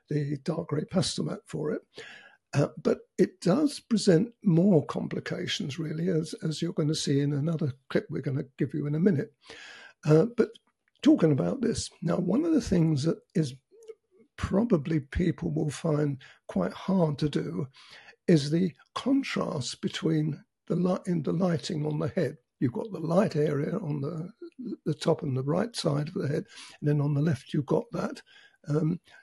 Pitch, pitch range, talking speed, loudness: 165 Hz, 150-200 Hz, 185 wpm, -28 LUFS